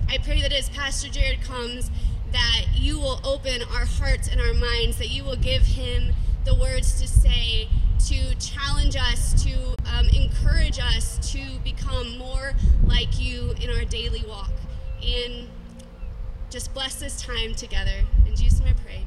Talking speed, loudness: 165 wpm, -25 LUFS